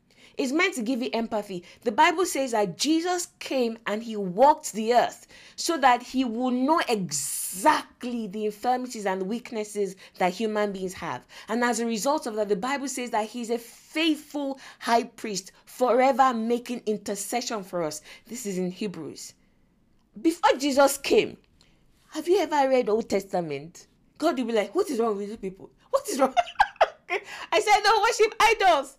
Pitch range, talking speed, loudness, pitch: 210-290 Hz, 170 wpm, -25 LUFS, 240 Hz